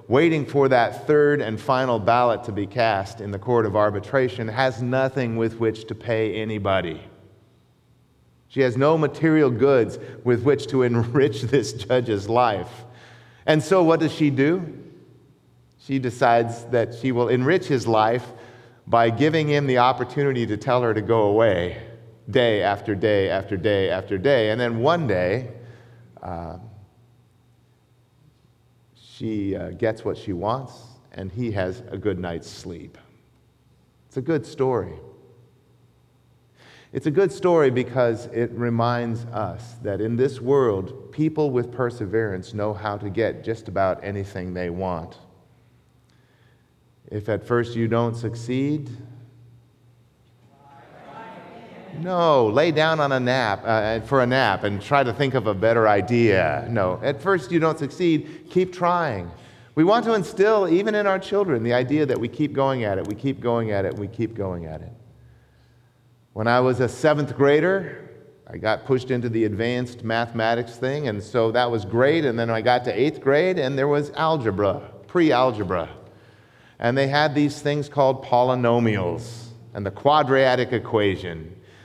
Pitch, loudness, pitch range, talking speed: 120 Hz, -22 LUFS, 110-135 Hz, 155 wpm